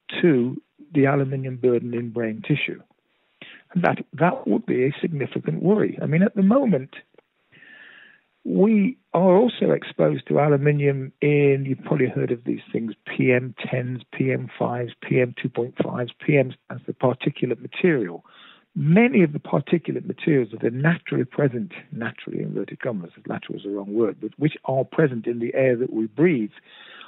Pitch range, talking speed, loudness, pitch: 125-170 Hz, 150 wpm, -22 LUFS, 140 Hz